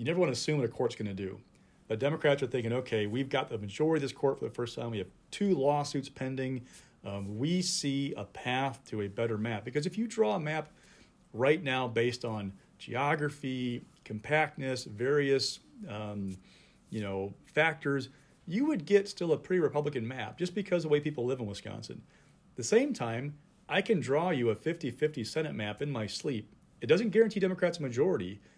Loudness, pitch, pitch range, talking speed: -32 LUFS, 135 Hz, 115-155 Hz, 205 wpm